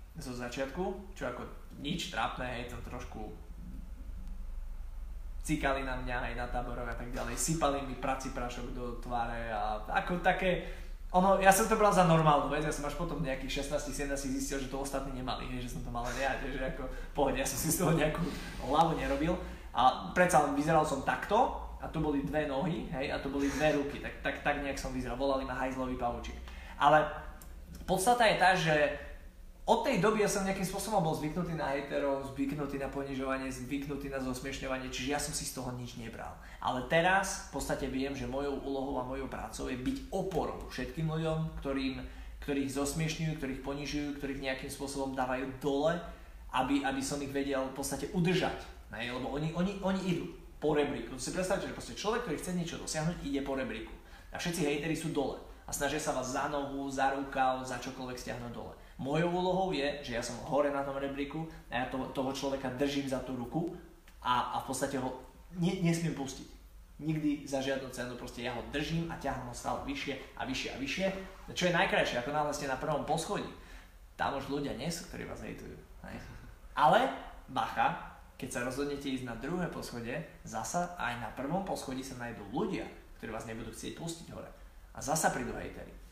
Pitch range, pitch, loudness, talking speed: 130-155 Hz, 140 Hz, -34 LUFS, 195 wpm